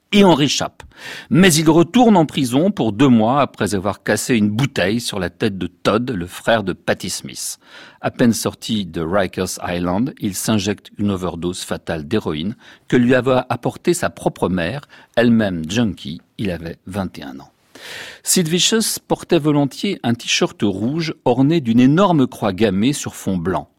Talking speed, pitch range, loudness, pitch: 165 wpm, 105-160 Hz, -18 LUFS, 125 Hz